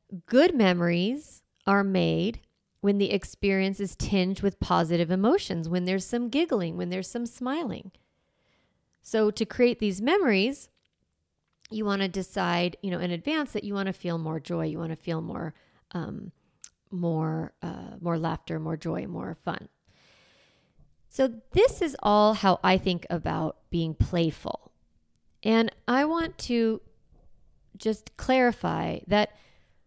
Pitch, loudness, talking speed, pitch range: 195 Hz, -27 LUFS, 145 wpm, 175-230 Hz